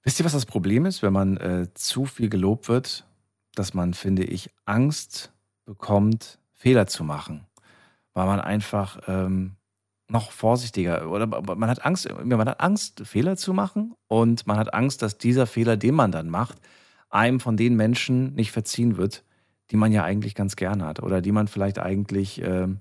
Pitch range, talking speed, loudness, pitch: 95-120 Hz, 180 wpm, -24 LUFS, 105 Hz